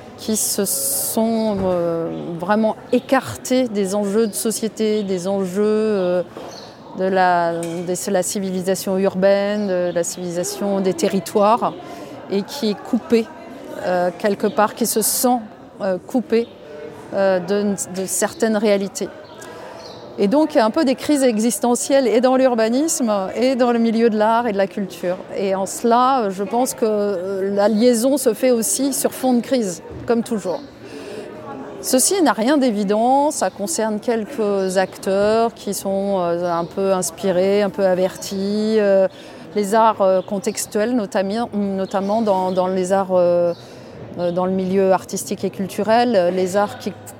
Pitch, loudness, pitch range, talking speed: 205 Hz, -19 LUFS, 190-230 Hz, 145 wpm